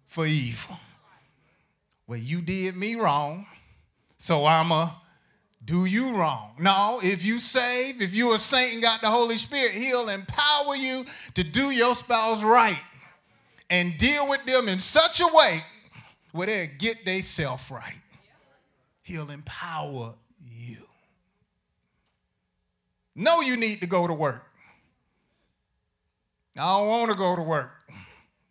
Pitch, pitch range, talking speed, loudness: 185 Hz, 145-235 Hz, 135 wpm, -23 LUFS